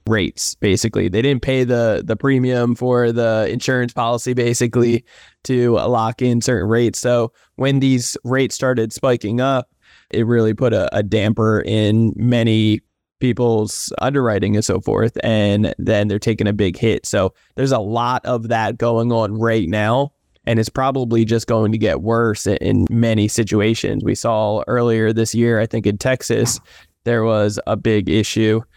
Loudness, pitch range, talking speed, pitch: -17 LUFS, 110-125 Hz, 165 wpm, 115 Hz